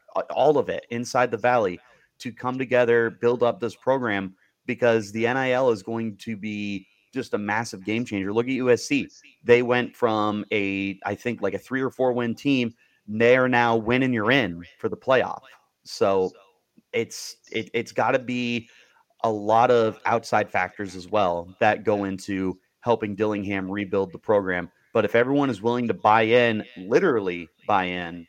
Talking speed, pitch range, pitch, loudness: 180 wpm, 100-125 Hz, 115 Hz, -24 LUFS